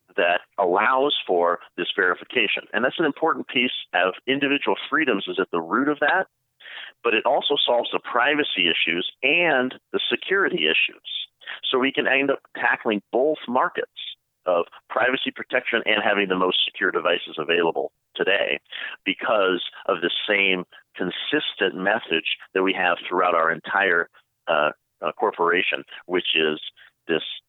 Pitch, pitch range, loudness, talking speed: 115 Hz, 95-135 Hz, -22 LUFS, 145 wpm